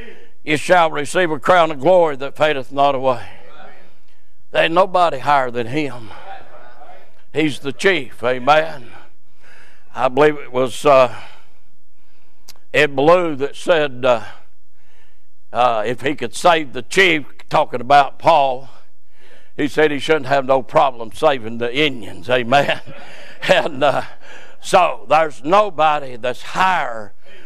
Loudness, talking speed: -17 LUFS, 130 wpm